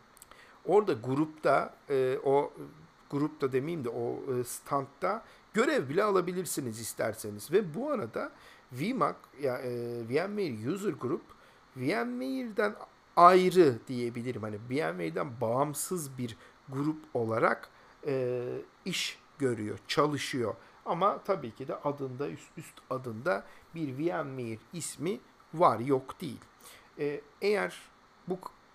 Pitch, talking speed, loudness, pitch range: 140 Hz, 110 wpm, -31 LUFS, 125-175 Hz